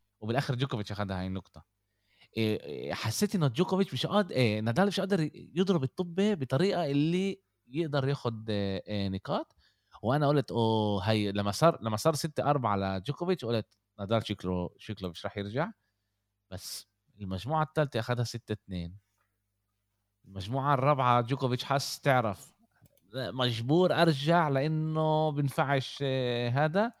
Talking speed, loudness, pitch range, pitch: 130 wpm, -30 LUFS, 100-155 Hz, 125 Hz